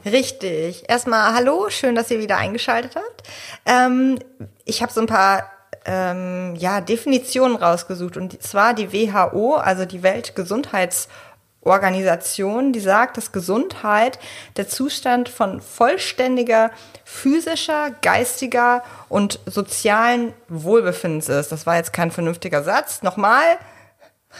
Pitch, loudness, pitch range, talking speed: 225 Hz, -19 LUFS, 185-250 Hz, 115 wpm